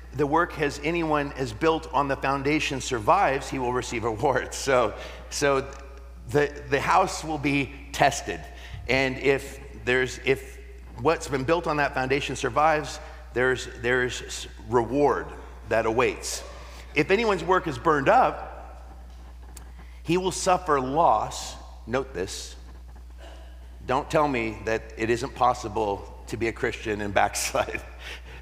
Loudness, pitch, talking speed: -25 LUFS, 130 Hz, 135 wpm